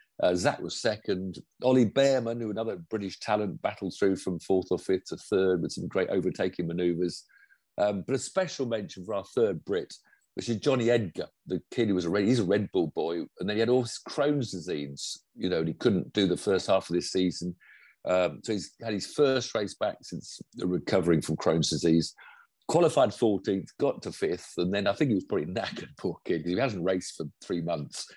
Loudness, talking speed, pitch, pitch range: -29 LUFS, 215 wpm, 95 Hz, 90-115 Hz